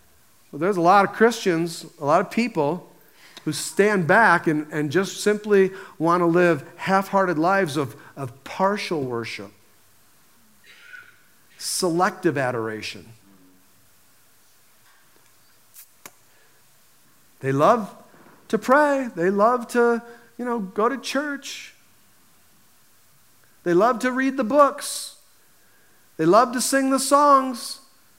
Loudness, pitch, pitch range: -21 LUFS, 195 Hz, 155-250 Hz